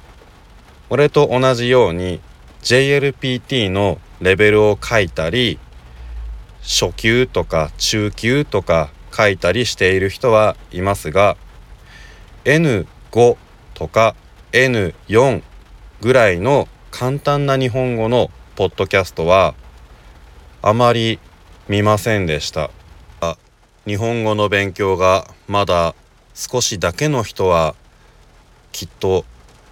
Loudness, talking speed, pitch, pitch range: -16 LUFS, 190 characters per minute, 100 Hz, 80-120 Hz